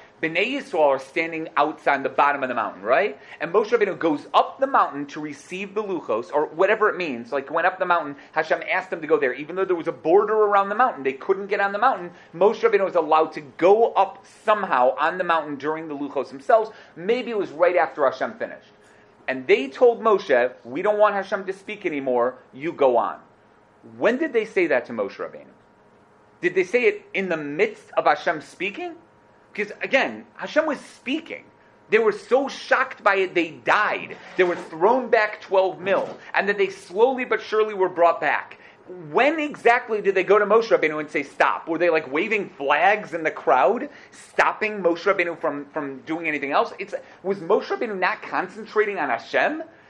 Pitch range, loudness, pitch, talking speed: 155-230 Hz, -22 LUFS, 190 Hz, 205 wpm